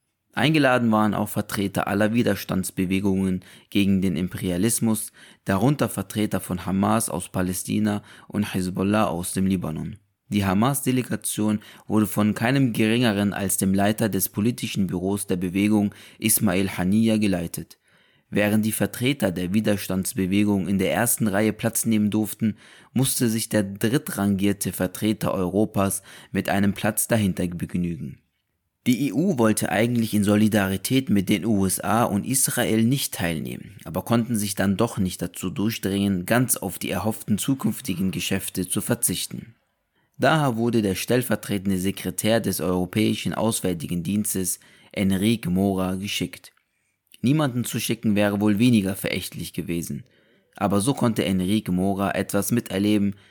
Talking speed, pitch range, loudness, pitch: 130 wpm, 95-115 Hz, -23 LUFS, 105 Hz